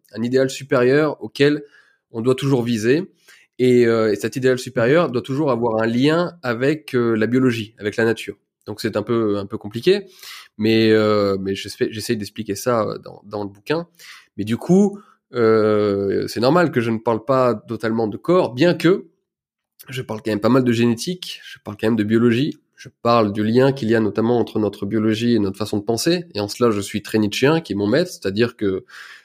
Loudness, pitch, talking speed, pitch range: -19 LUFS, 115 Hz, 210 wpm, 105-130 Hz